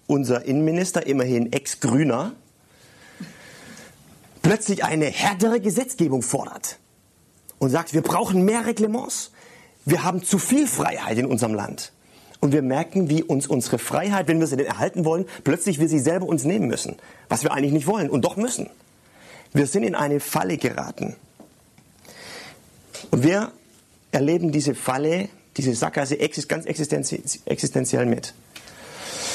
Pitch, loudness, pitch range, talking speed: 160 Hz, -23 LUFS, 145-195 Hz, 135 wpm